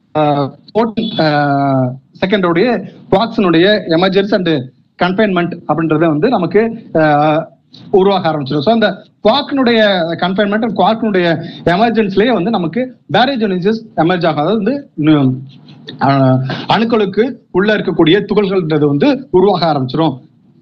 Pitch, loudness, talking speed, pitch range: 185 Hz, -13 LUFS, 90 wpm, 155-215 Hz